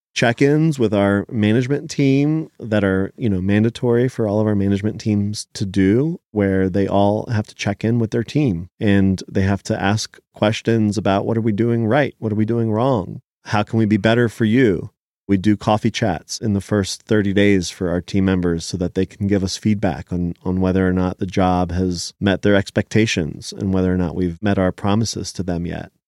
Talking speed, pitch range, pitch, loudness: 215 wpm, 95-115 Hz, 105 Hz, -19 LUFS